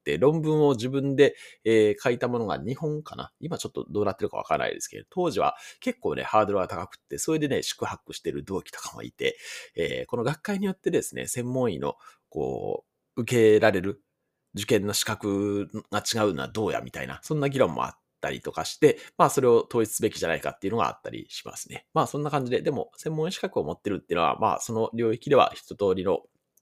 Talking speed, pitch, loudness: 430 characters per minute, 140 Hz, -26 LUFS